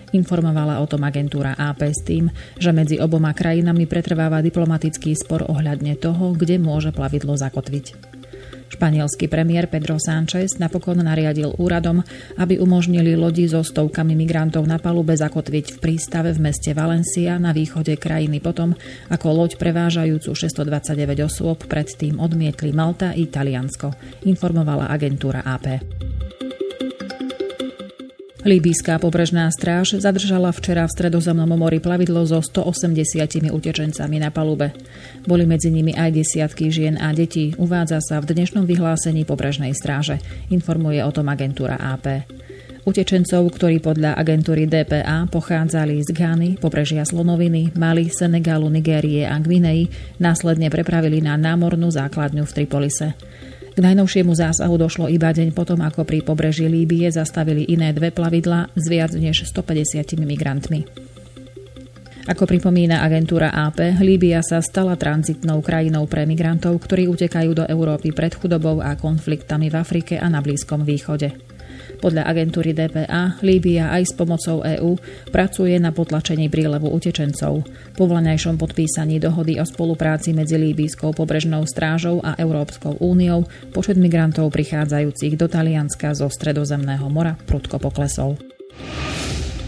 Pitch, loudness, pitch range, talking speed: 160 Hz, -19 LUFS, 150-170 Hz, 130 wpm